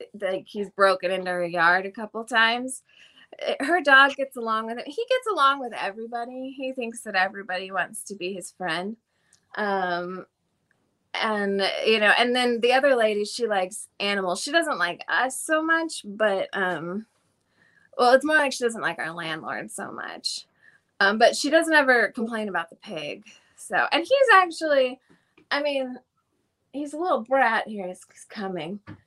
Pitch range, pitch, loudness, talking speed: 195-265 Hz, 225 Hz, -23 LUFS, 170 wpm